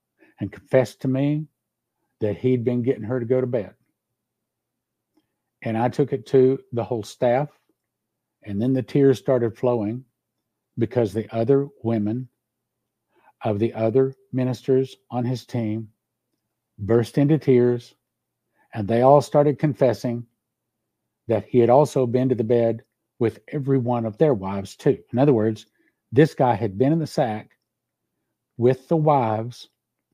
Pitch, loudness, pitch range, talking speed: 120 Hz, -22 LUFS, 115-130 Hz, 145 wpm